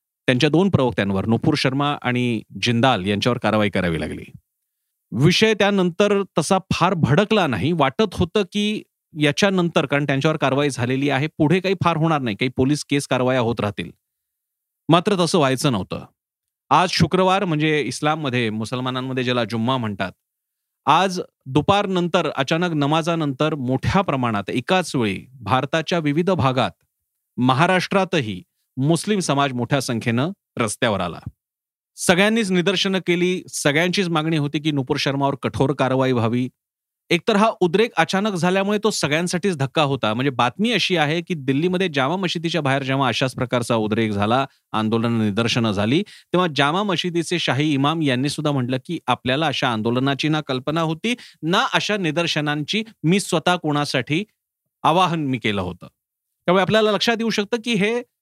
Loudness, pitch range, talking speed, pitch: -20 LUFS, 130-180 Hz, 140 wpm, 150 Hz